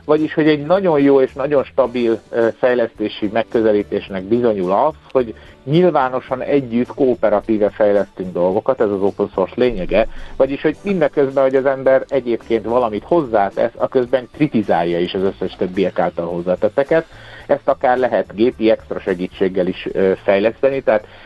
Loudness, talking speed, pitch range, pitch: -17 LUFS, 140 wpm, 105-135 Hz, 120 Hz